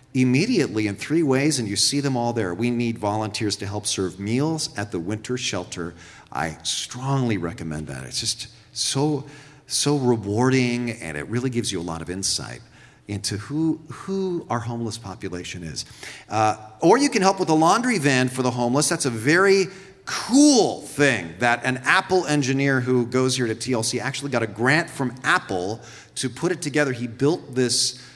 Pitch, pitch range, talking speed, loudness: 125 Hz, 110-145 Hz, 180 wpm, -22 LUFS